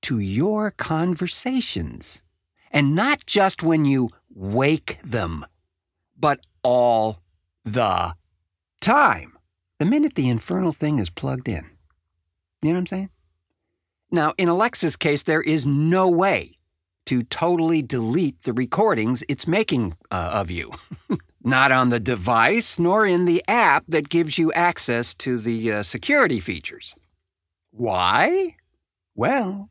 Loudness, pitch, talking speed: -21 LUFS, 125 Hz, 130 wpm